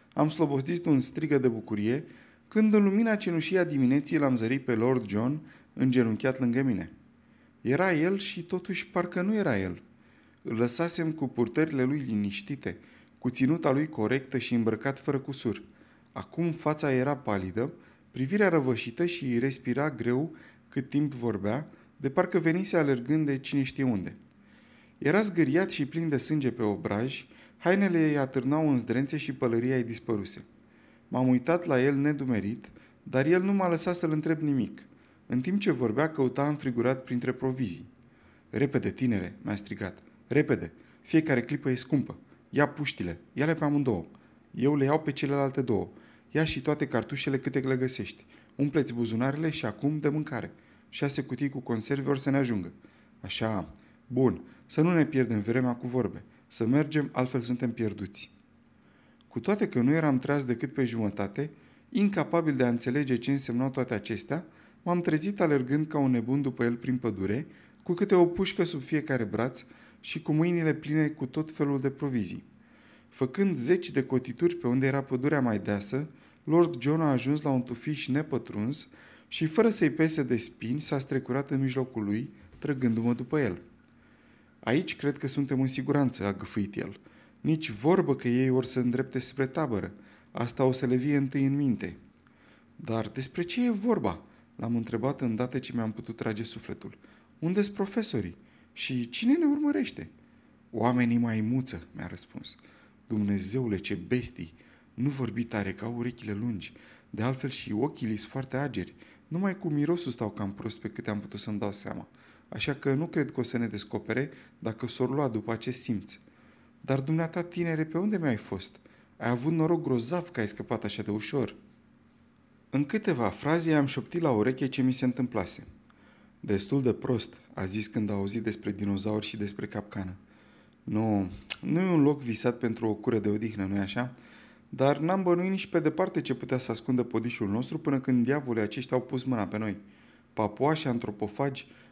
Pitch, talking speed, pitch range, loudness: 130 Hz, 170 wpm, 115-150 Hz, -29 LUFS